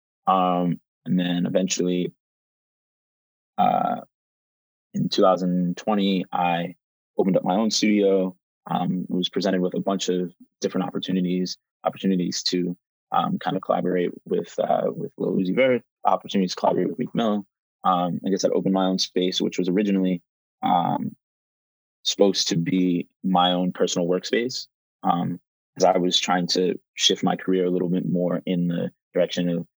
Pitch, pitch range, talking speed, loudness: 90 Hz, 90-95 Hz, 150 wpm, -23 LUFS